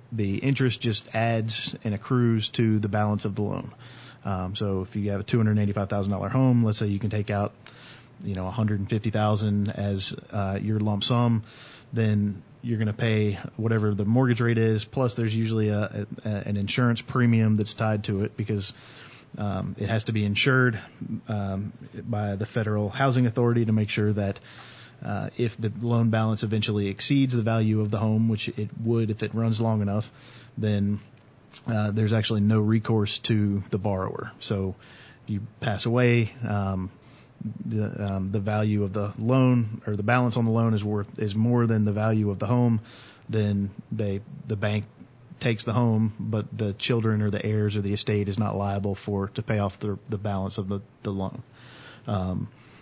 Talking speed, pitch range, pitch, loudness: 195 wpm, 105-115 Hz, 110 Hz, -26 LUFS